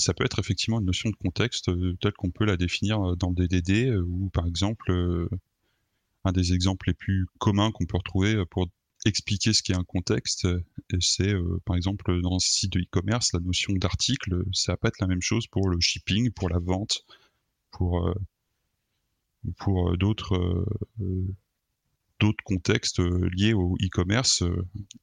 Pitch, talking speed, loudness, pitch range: 95 Hz, 175 wpm, -26 LUFS, 90-105 Hz